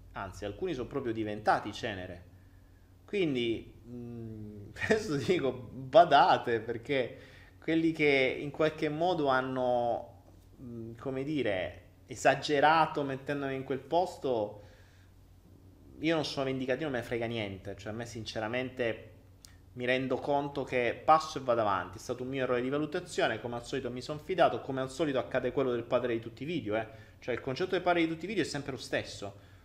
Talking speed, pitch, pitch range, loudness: 170 wpm, 125 Hz, 105-140 Hz, -31 LUFS